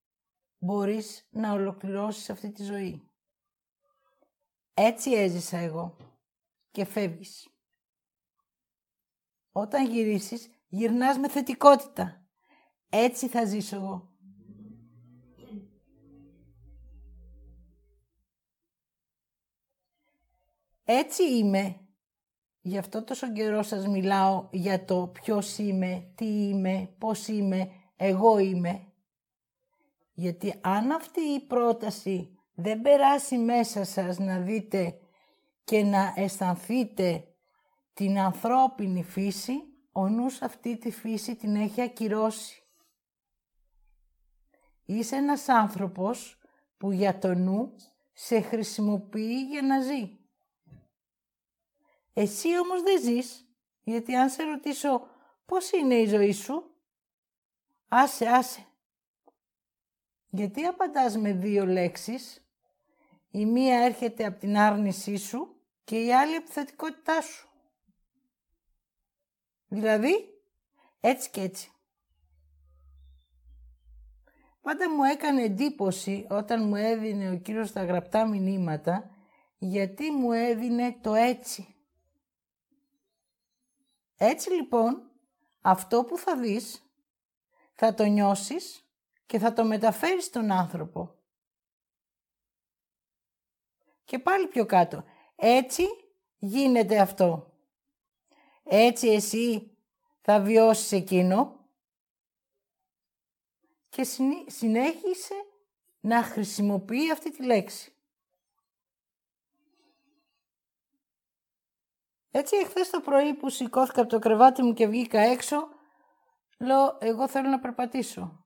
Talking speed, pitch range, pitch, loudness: 90 wpm, 195-270 Hz, 225 Hz, -27 LUFS